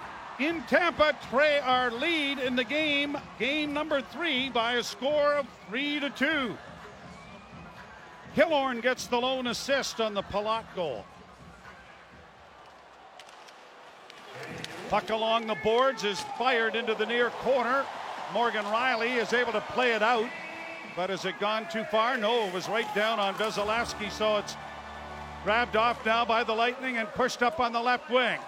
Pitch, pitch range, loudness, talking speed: 235 Hz, 215-265 Hz, -28 LUFS, 155 wpm